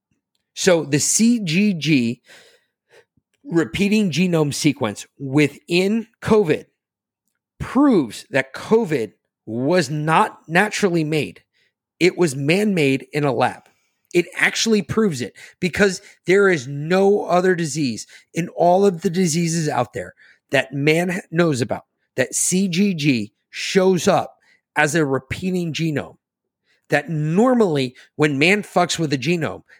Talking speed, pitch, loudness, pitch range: 120 wpm, 170 Hz, -19 LUFS, 150-195 Hz